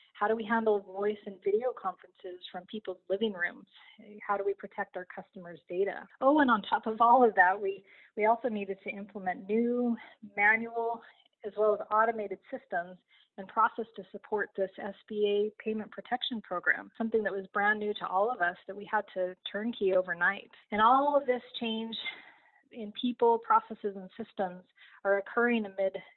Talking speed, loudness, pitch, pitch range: 175 wpm, -30 LUFS, 210 Hz, 195-230 Hz